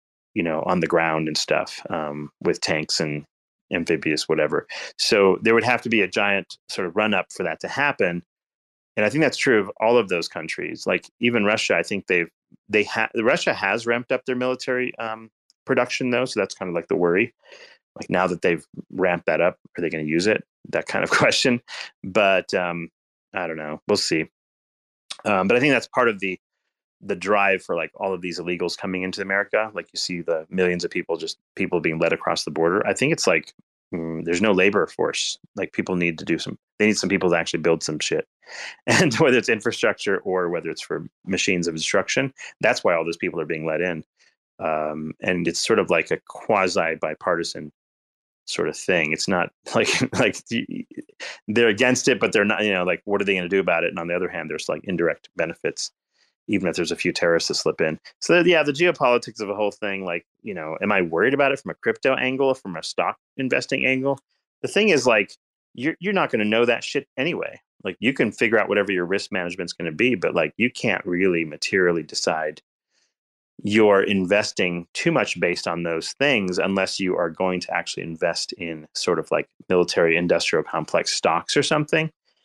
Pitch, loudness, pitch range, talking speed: 95 Hz, -22 LUFS, 85-120 Hz, 220 wpm